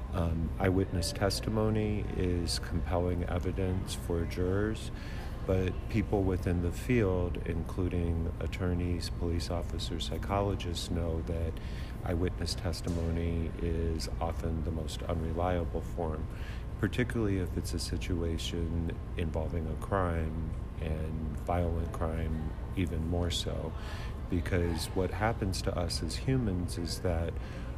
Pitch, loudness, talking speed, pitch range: 85 Hz, -33 LUFS, 110 wpm, 80-95 Hz